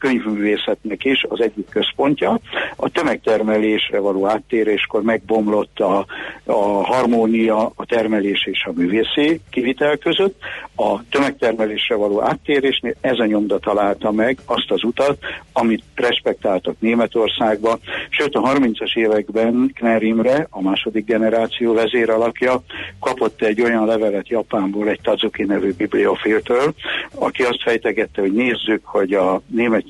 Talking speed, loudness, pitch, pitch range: 125 wpm, -18 LUFS, 110 Hz, 105-120 Hz